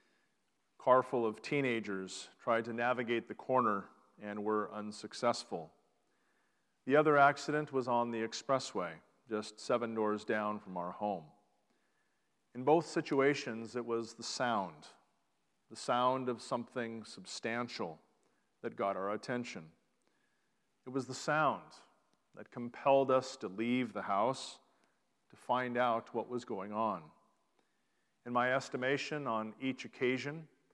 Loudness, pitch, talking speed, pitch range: -35 LUFS, 120 Hz, 130 wpm, 110-130 Hz